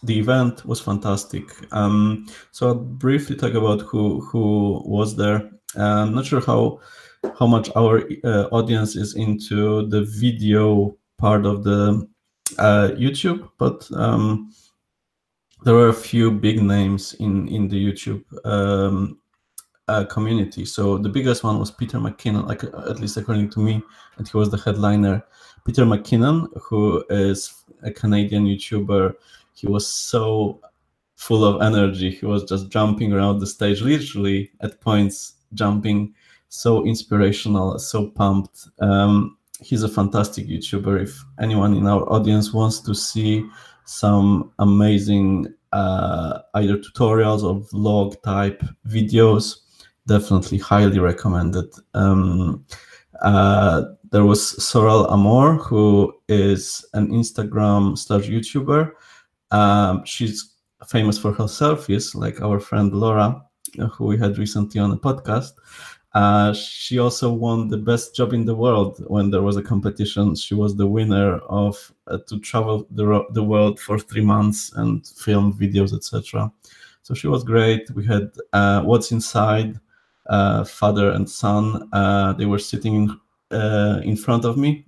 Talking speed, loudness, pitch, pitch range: 145 wpm, -19 LUFS, 105 Hz, 100-115 Hz